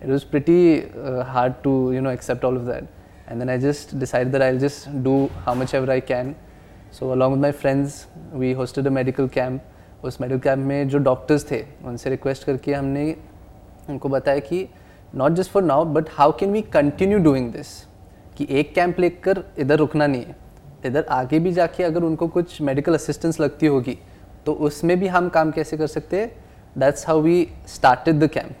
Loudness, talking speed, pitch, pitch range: -21 LUFS, 195 wpm, 140 Hz, 130-155 Hz